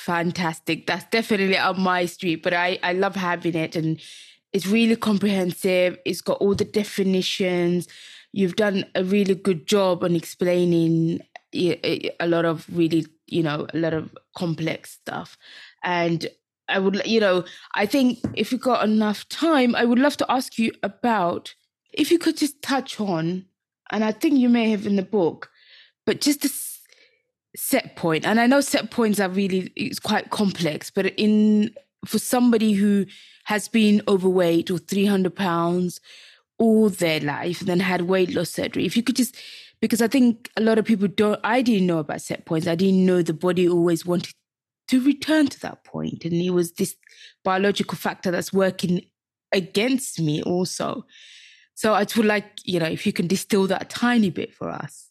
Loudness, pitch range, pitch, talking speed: -22 LUFS, 175-220 Hz, 195 Hz, 180 wpm